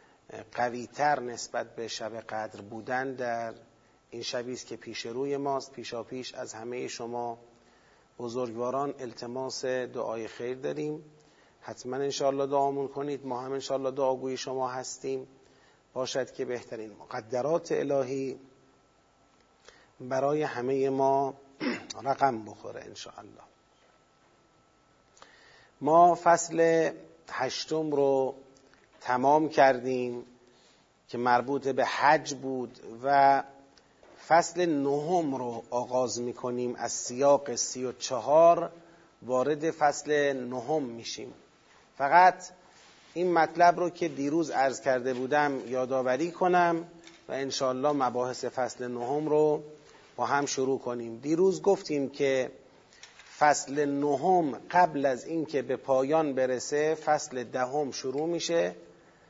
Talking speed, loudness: 115 wpm, -29 LUFS